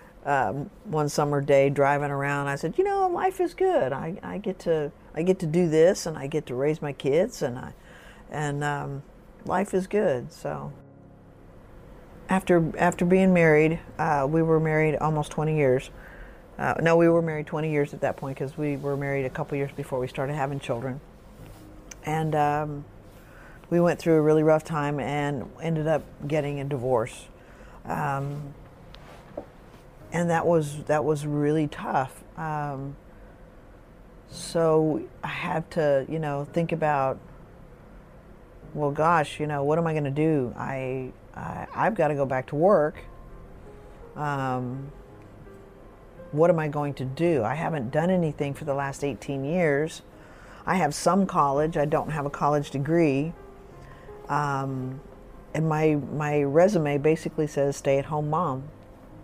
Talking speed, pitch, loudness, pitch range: 160 wpm, 150 Hz, -25 LUFS, 140-165 Hz